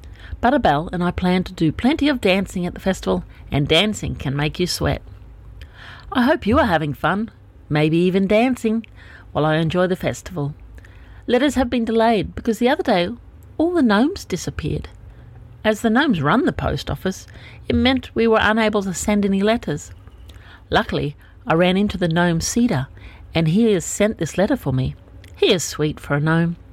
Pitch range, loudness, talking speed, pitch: 140-220 Hz, -19 LUFS, 180 wpm, 175 Hz